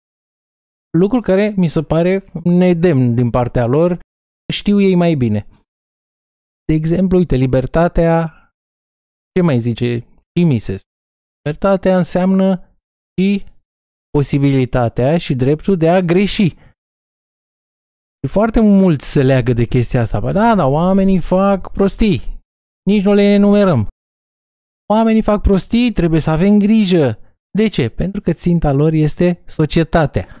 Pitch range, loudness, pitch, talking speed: 125-190 Hz, -14 LUFS, 165 Hz, 120 wpm